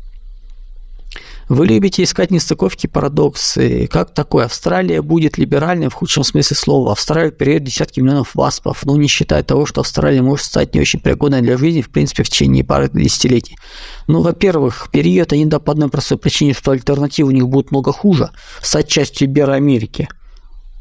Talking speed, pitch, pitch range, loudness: 170 wpm, 140 Hz, 120-150 Hz, -14 LUFS